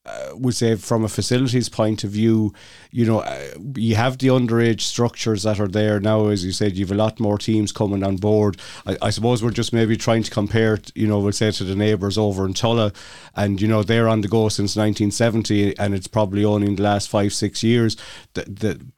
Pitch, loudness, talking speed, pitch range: 110 Hz, -20 LUFS, 230 wpm, 105-115 Hz